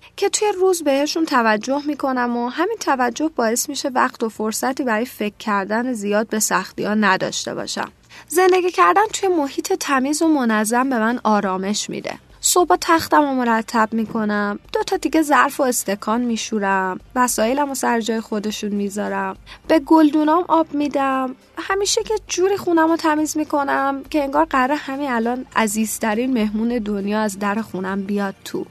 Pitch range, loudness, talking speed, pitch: 215-310 Hz, -19 LUFS, 160 wpm, 250 Hz